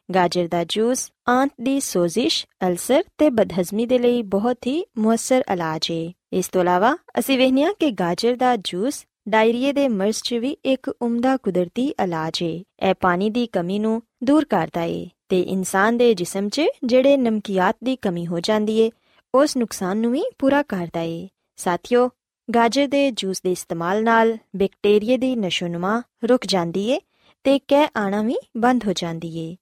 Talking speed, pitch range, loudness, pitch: 165 wpm, 185-255 Hz, -21 LUFS, 225 Hz